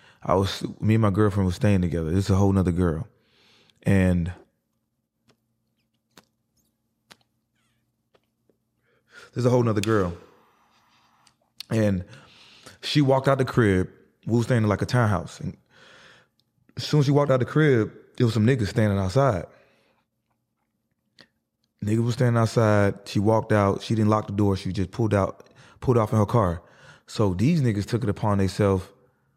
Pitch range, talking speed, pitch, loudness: 95-120 Hz, 160 wpm, 110 Hz, -23 LUFS